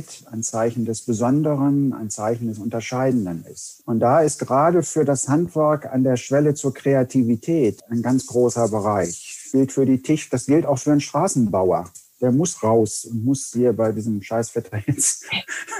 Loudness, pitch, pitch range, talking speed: -20 LUFS, 130 Hz, 115-140 Hz, 175 wpm